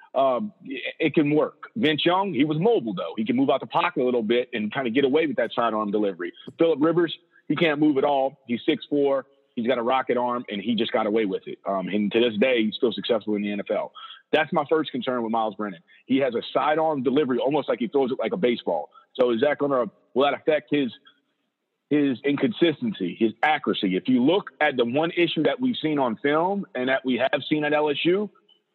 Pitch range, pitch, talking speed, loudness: 120-160 Hz, 140 Hz, 235 wpm, -24 LUFS